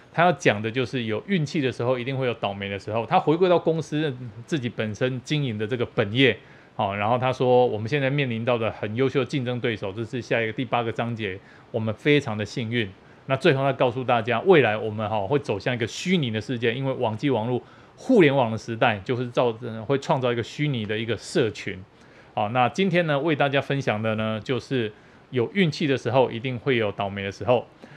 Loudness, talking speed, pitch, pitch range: -24 LUFS, 335 characters per minute, 125 Hz, 110-140 Hz